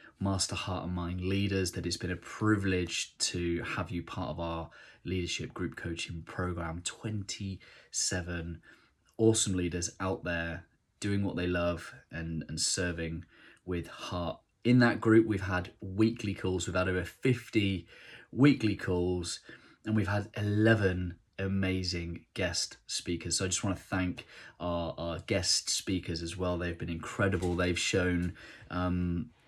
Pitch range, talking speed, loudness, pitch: 85-100 Hz, 145 wpm, -32 LUFS, 90 Hz